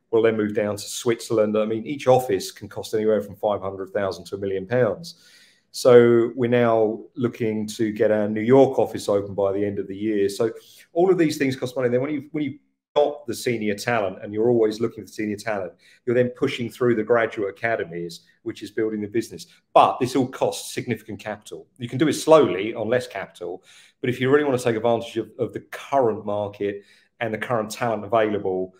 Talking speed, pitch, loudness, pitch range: 215 wpm, 115 Hz, -22 LUFS, 105-125 Hz